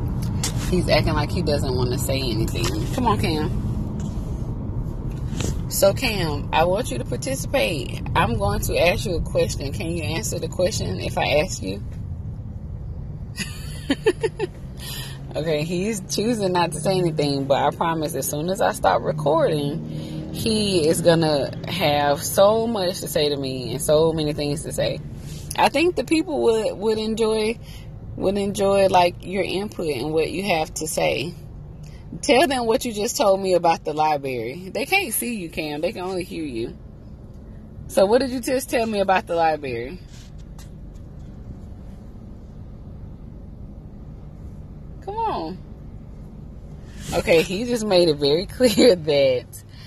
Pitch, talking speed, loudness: 160 Hz, 150 wpm, -22 LUFS